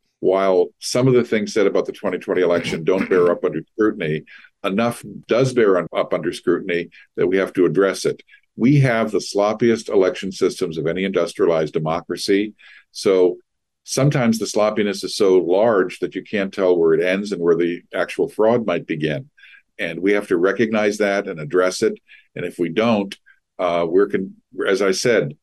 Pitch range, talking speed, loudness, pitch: 95-120 Hz, 180 wpm, -19 LUFS, 105 Hz